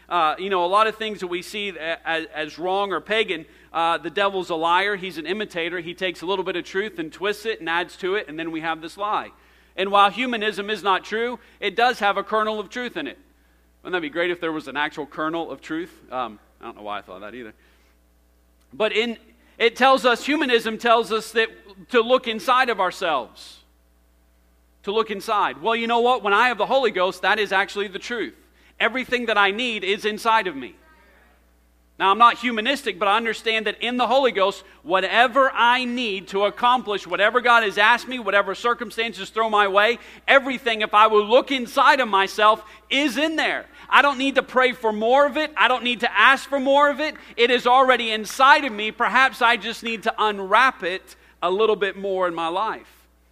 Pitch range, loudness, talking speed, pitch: 180-240 Hz, -21 LUFS, 225 wpm, 215 Hz